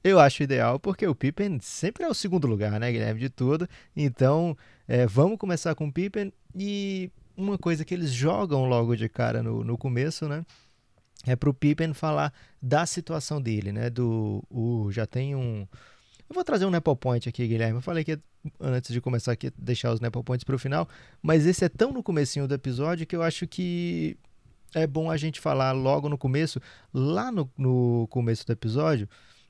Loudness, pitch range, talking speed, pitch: -27 LUFS, 120-160 Hz, 195 wpm, 140 Hz